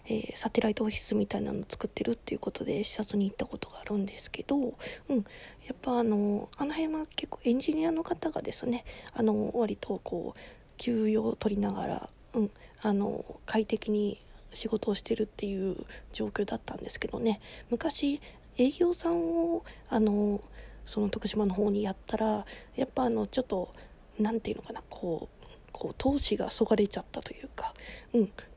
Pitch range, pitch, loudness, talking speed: 210-255 Hz, 225 Hz, -32 LUFS, 345 characters per minute